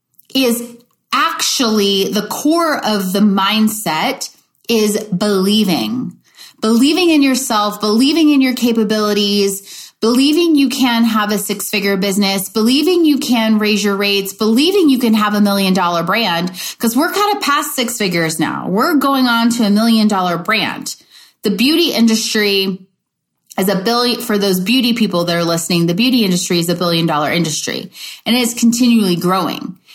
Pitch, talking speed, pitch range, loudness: 215 Hz, 160 wpm, 195-245 Hz, -14 LUFS